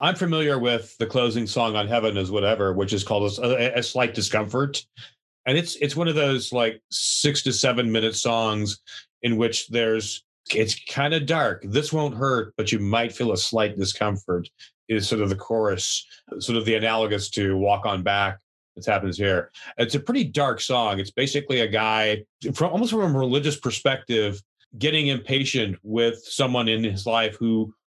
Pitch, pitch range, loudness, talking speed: 115 Hz, 105-135 Hz, -23 LUFS, 185 wpm